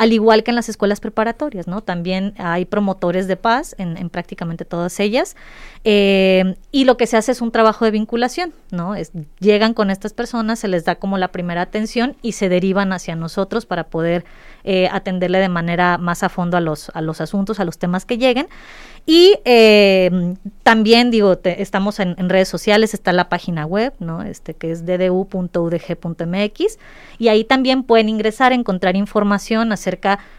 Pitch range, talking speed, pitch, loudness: 180-225 Hz, 185 wpm, 195 Hz, -17 LUFS